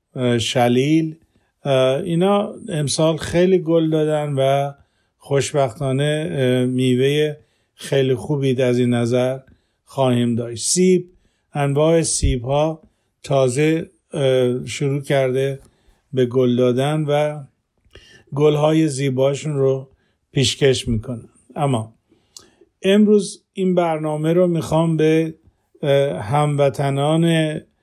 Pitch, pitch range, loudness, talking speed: 140 Hz, 125-155 Hz, -19 LUFS, 90 wpm